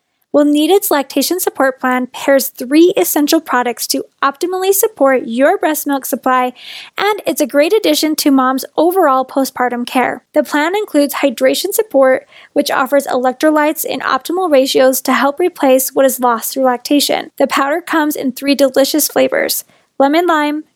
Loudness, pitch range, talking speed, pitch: -13 LUFS, 265-315 Hz, 155 wpm, 280 Hz